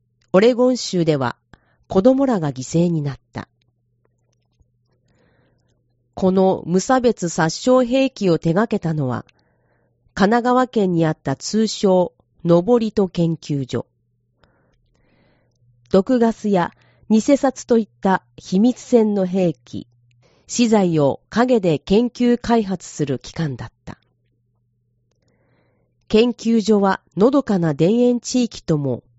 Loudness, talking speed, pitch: -18 LUFS, 195 characters per minute, 170 Hz